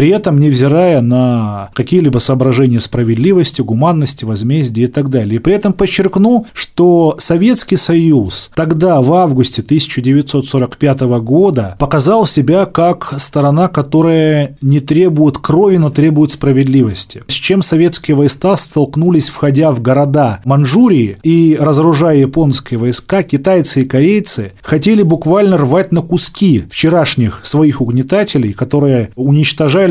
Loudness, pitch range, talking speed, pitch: -11 LUFS, 130-170 Hz, 120 wpm, 150 Hz